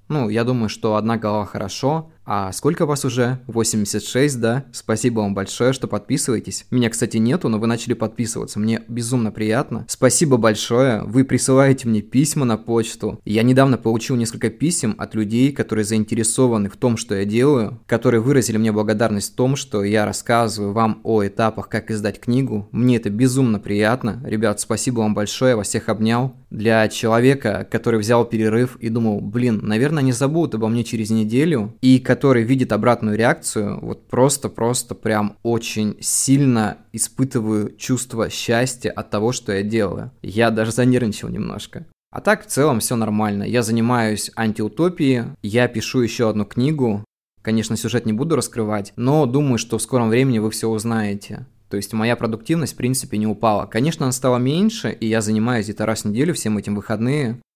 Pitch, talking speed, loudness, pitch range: 115 Hz, 170 wpm, -19 LUFS, 110-125 Hz